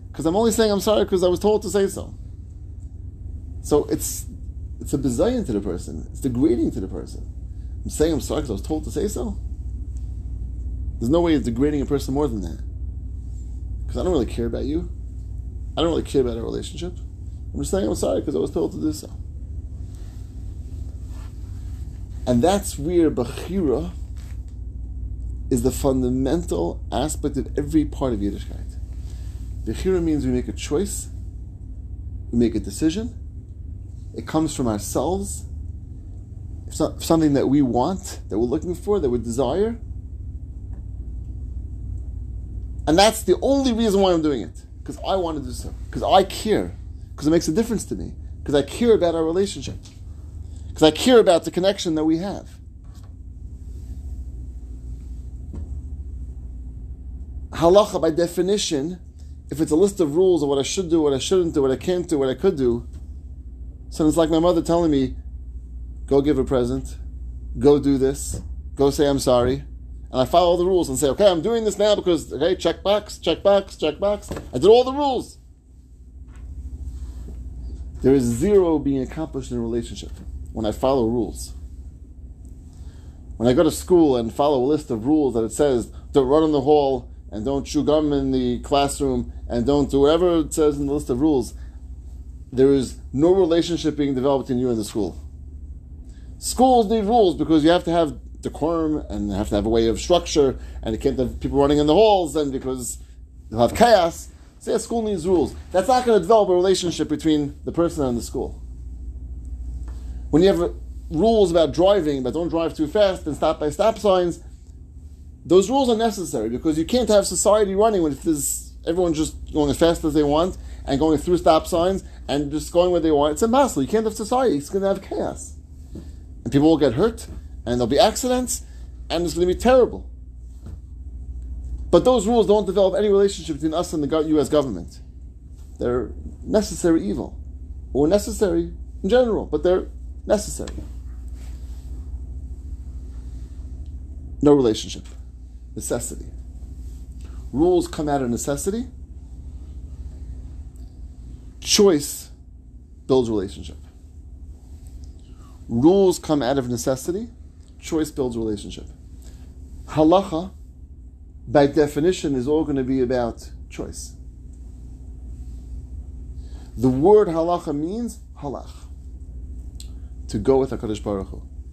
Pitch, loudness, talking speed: 100 Hz, -21 LUFS, 165 wpm